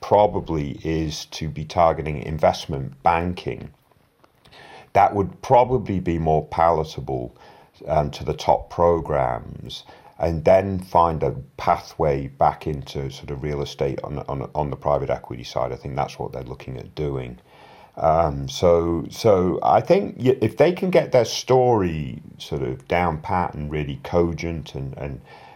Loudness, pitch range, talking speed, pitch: -22 LUFS, 70-85 Hz, 150 wpm, 80 Hz